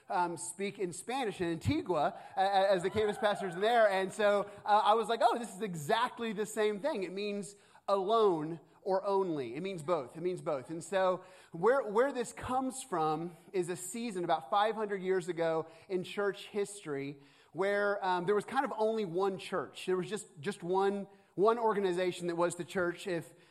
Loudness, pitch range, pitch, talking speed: -33 LUFS, 175-210 Hz, 195 Hz, 190 wpm